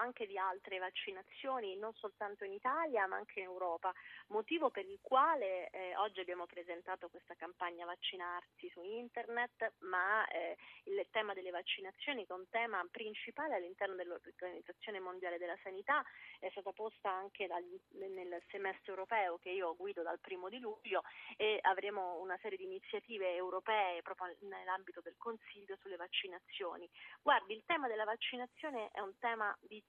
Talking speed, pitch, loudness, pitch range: 155 wpm, 195 Hz, -41 LUFS, 180-225 Hz